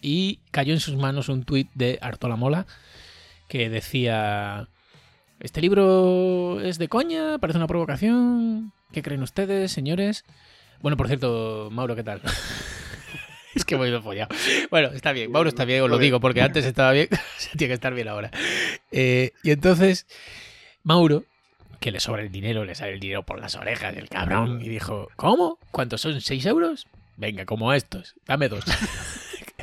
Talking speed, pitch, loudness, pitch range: 170 wpm, 135 Hz, -23 LUFS, 115-170 Hz